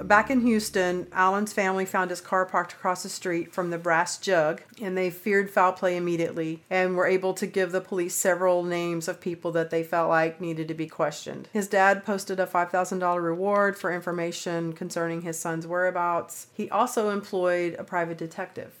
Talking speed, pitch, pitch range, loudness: 190 wpm, 180 Hz, 170-190 Hz, -26 LUFS